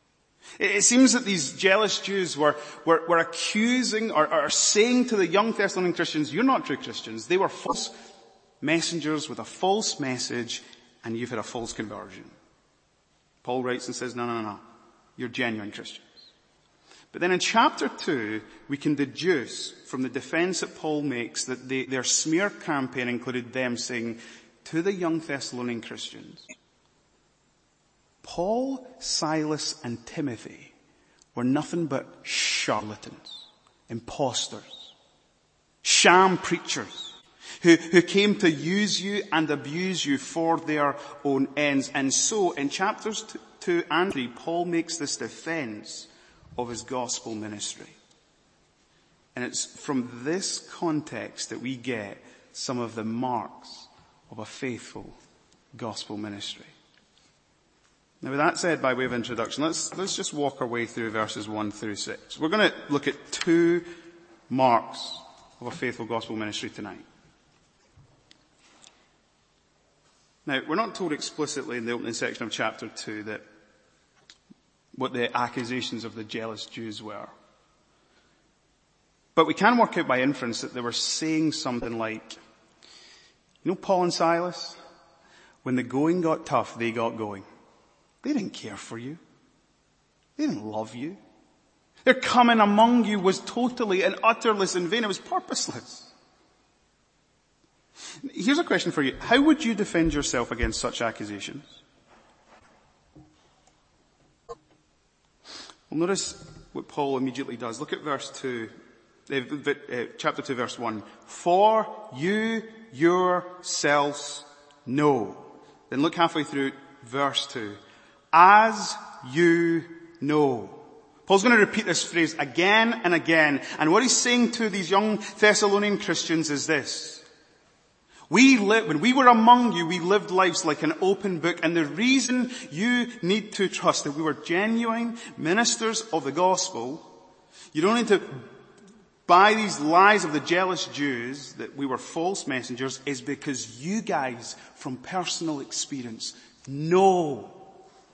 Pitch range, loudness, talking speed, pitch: 125-190 Hz, -25 LUFS, 140 wpm, 155 Hz